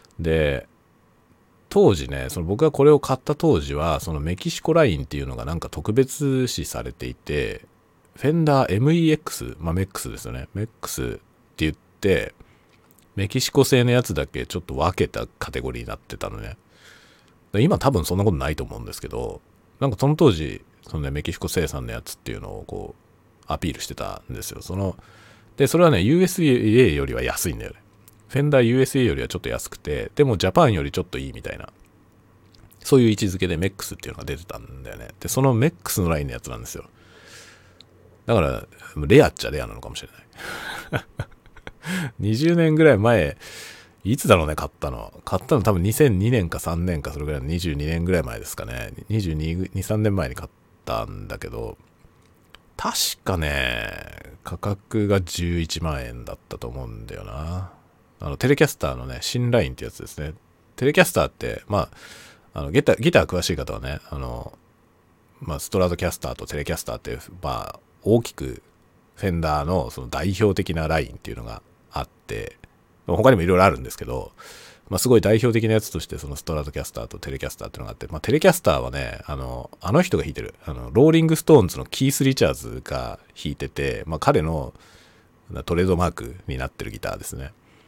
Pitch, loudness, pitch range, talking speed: 95 Hz, -22 LUFS, 80-115 Hz, 380 characters per minute